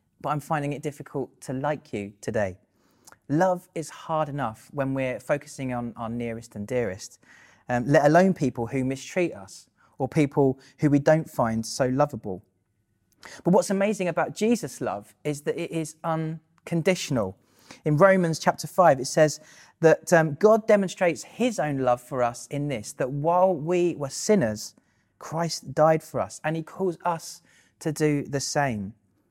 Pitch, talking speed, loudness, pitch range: 150 Hz, 165 wpm, -25 LUFS, 130-165 Hz